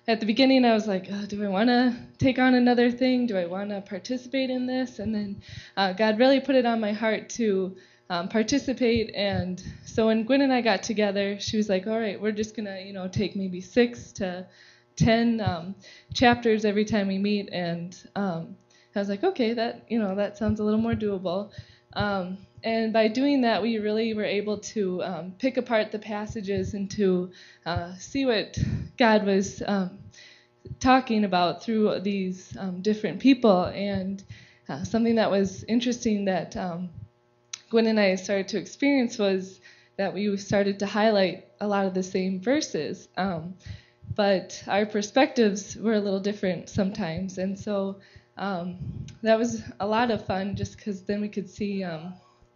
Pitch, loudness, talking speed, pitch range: 205 Hz, -26 LUFS, 185 wpm, 190-225 Hz